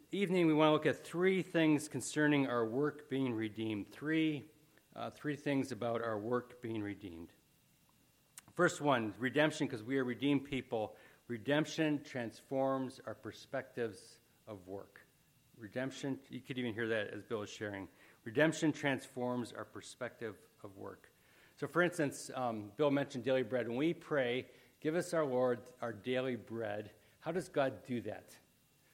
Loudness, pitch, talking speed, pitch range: -37 LUFS, 130 Hz, 155 wpm, 115-150 Hz